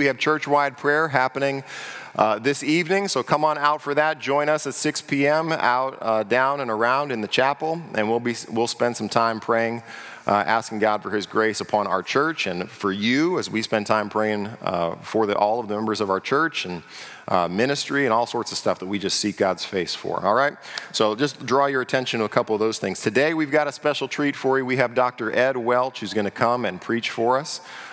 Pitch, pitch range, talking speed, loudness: 125 Hz, 110-145 Hz, 240 wpm, -22 LUFS